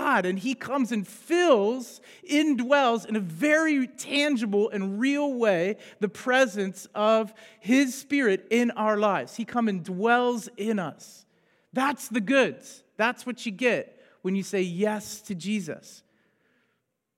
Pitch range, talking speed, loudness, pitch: 205-265 Hz, 140 wpm, -26 LUFS, 225 Hz